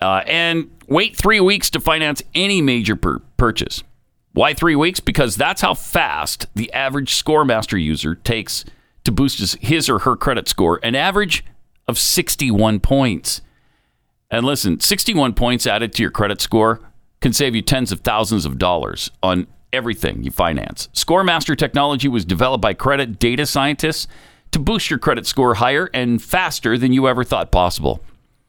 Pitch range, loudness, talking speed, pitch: 110-150 Hz, -17 LUFS, 165 wpm, 130 Hz